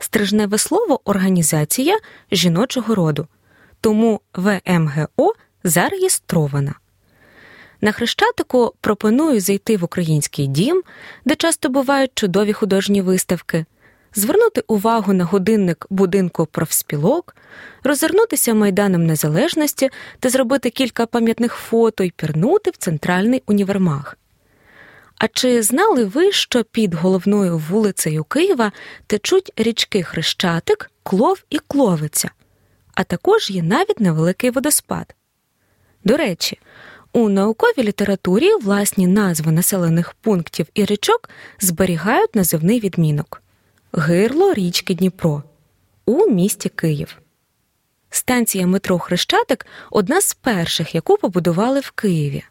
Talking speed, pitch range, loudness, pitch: 105 wpm, 175-245 Hz, -17 LUFS, 205 Hz